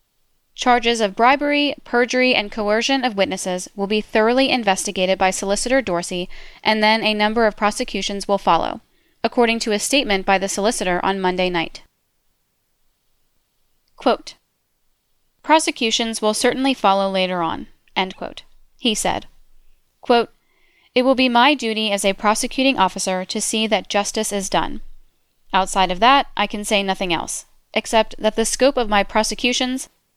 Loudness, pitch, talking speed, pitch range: -19 LUFS, 215 Hz, 150 wpm, 195-245 Hz